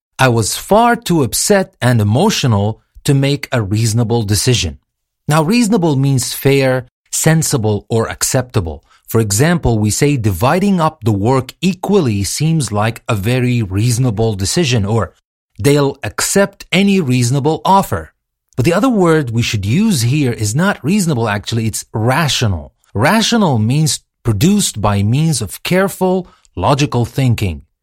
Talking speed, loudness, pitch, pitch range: 135 wpm, -14 LUFS, 130 Hz, 110-160 Hz